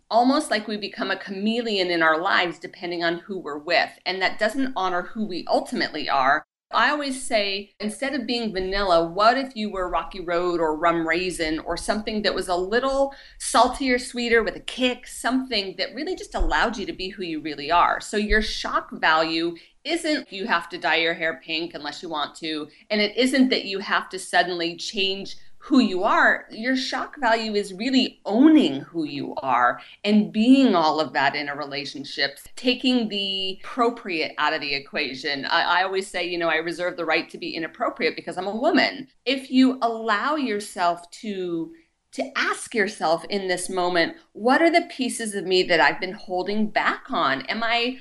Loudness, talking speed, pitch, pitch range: -23 LUFS, 195 wpm, 200 Hz, 175-245 Hz